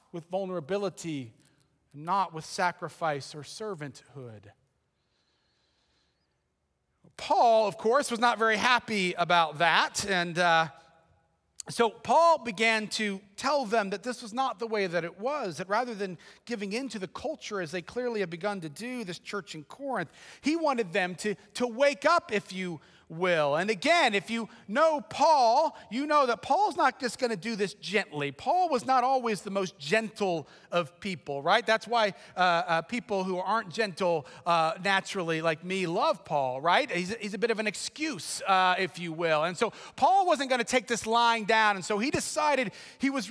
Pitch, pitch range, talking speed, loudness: 200 Hz, 170-235 Hz, 185 wpm, -28 LUFS